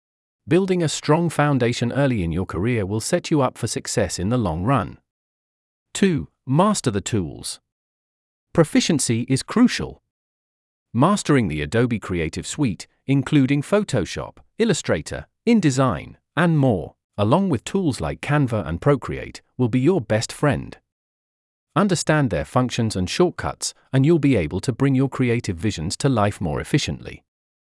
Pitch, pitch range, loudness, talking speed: 130 Hz, 105-150 Hz, -21 LUFS, 145 wpm